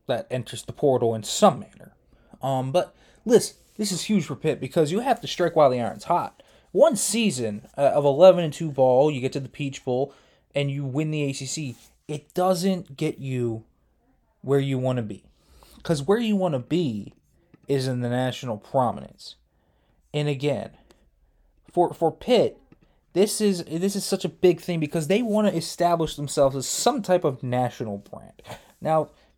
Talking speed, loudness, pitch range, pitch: 180 wpm, -24 LUFS, 130-180 Hz, 150 Hz